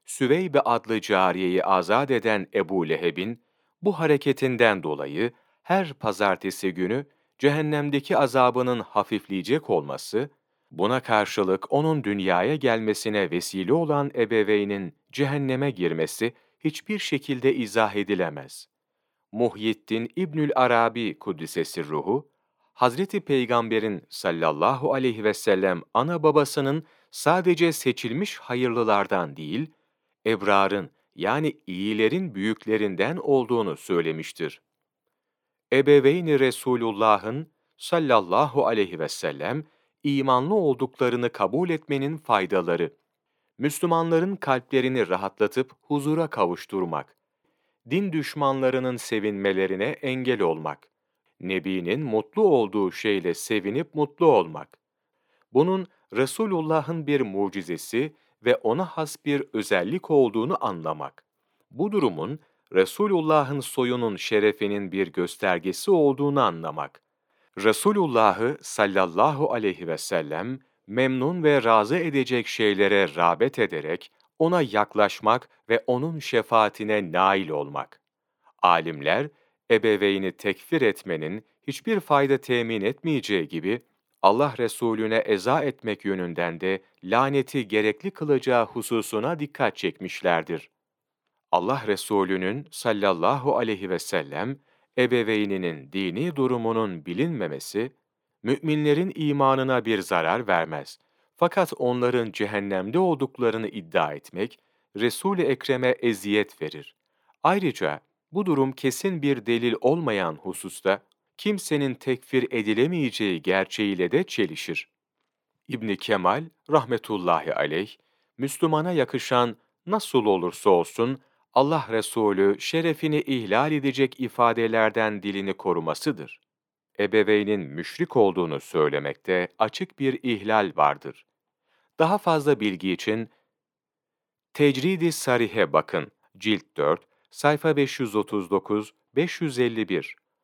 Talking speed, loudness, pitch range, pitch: 95 wpm, -24 LUFS, 105-145 Hz, 125 Hz